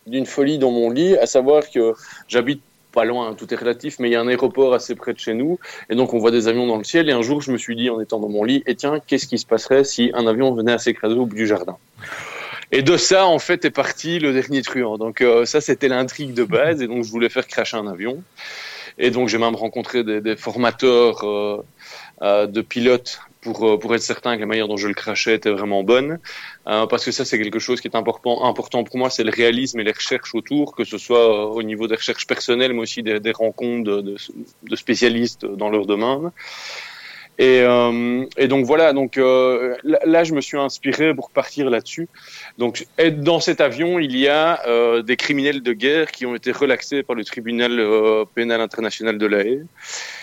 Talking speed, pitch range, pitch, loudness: 235 wpm, 115-135 Hz, 120 Hz, -19 LUFS